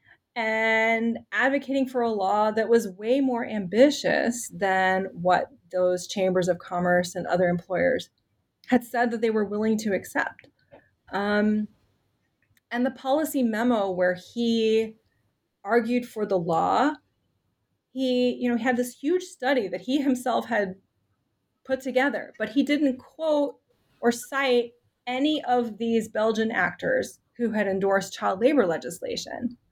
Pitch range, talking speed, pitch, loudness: 195-255 Hz, 135 wpm, 230 Hz, -25 LUFS